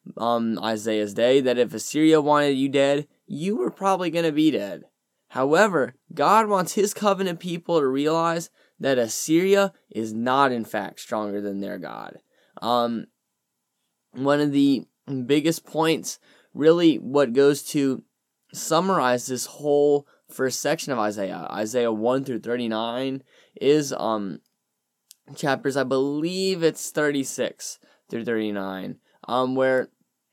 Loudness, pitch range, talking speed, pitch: -23 LUFS, 115-160 Hz, 130 wpm, 140 Hz